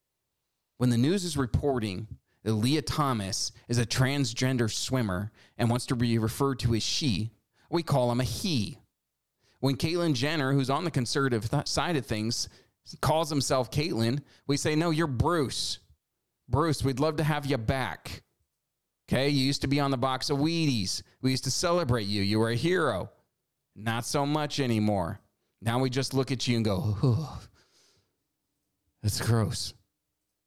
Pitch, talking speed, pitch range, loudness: 130 Hz, 165 wpm, 115-140 Hz, -28 LUFS